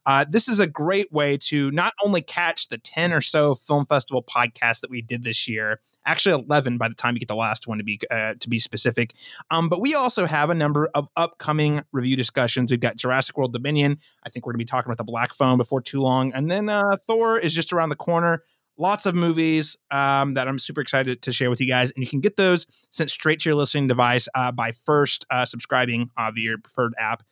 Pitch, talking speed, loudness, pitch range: 140 Hz, 245 wpm, -22 LUFS, 125-160 Hz